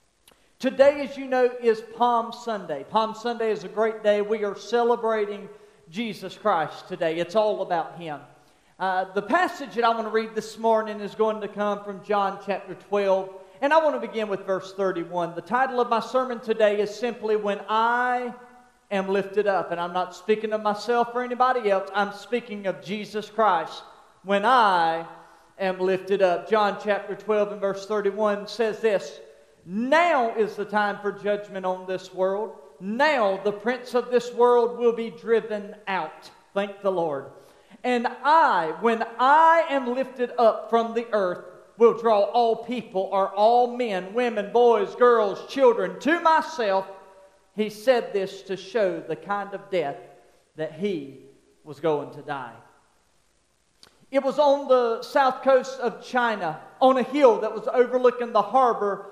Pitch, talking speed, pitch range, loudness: 215 Hz, 165 wpm, 195-240 Hz, -24 LUFS